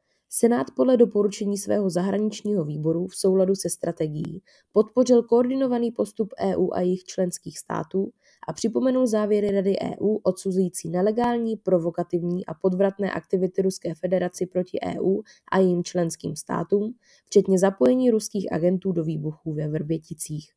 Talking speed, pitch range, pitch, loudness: 130 wpm, 175-210 Hz, 190 Hz, -24 LUFS